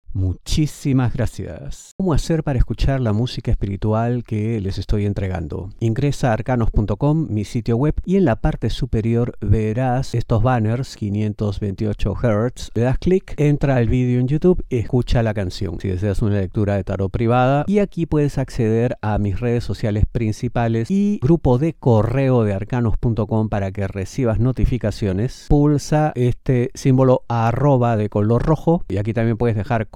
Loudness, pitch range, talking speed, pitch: -20 LUFS, 105-130 Hz, 160 wpm, 115 Hz